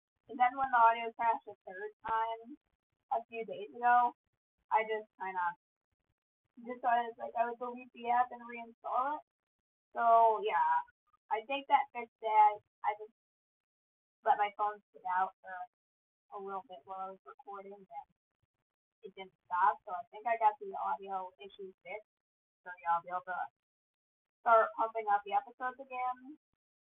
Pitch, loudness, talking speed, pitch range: 225 Hz, -34 LUFS, 170 wpm, 200-250 Hz